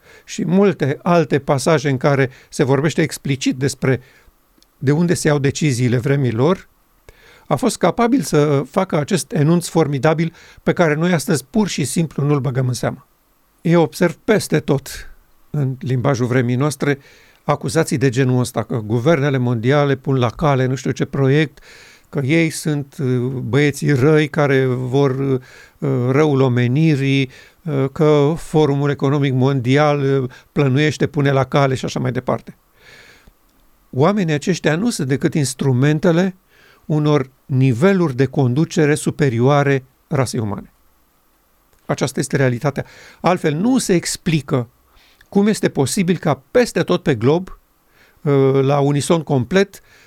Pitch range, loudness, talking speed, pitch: 135-165 Hz, -17 LUFS, 130 wpm, 145 Hz